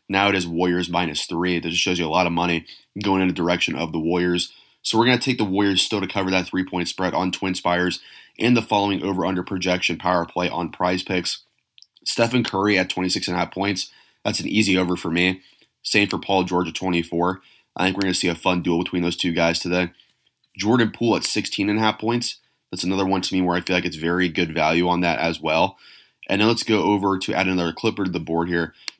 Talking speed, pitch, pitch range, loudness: 235 wpm, 90 Hz, 85-95 Hz, -21 LUFS